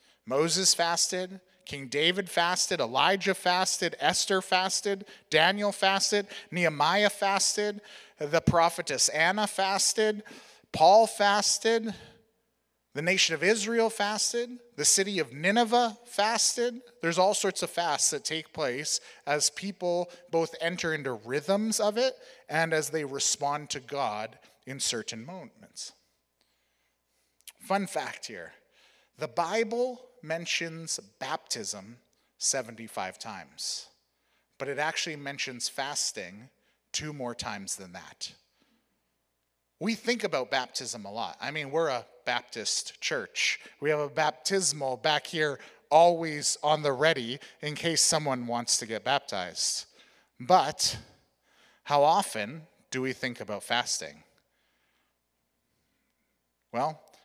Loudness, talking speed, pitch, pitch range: -28 LUFS, 115 wpm, 170 Hz, 140-200 Hz